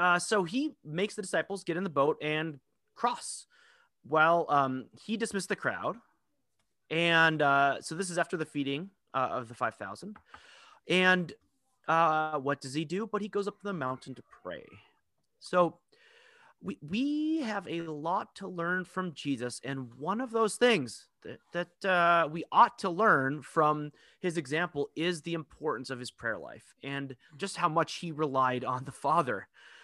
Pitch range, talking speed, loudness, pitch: 145-195 Hz, 175 wpm, -30 LUFS, 165 Hz